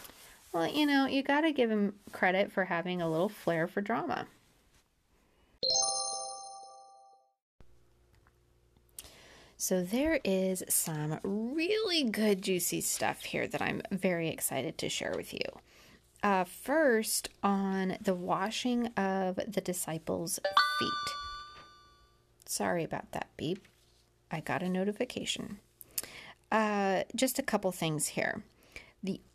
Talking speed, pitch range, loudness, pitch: 115 wpm, 160-240 Hz, -32 LUFS, 195 Hz